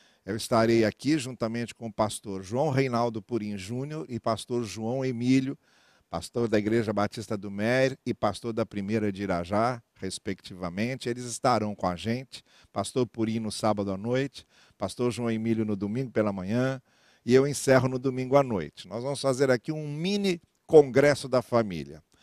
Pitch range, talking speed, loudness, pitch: 105-130 Hz, 165 wpm, -28 LUFS, 115 Hz